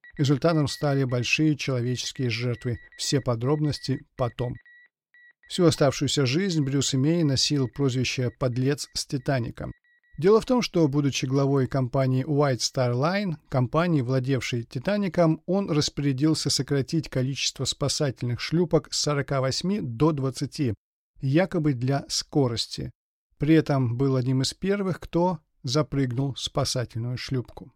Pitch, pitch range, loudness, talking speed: 140 Hz, 130-160 Hz, -25 LUFS, 120 wpm